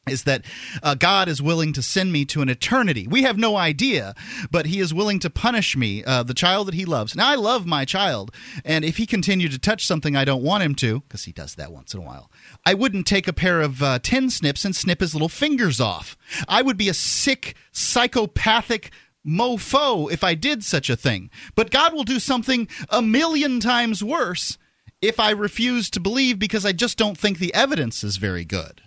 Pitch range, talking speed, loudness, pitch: 145-225 Hz, 220 wpm, -20 LUFS, 185 Hz